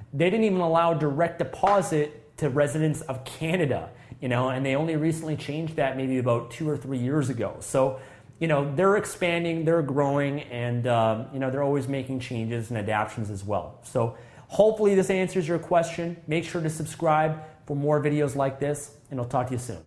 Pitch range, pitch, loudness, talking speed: 130-160 Hz, 145 Hz, -26 LUFS, 195 wpm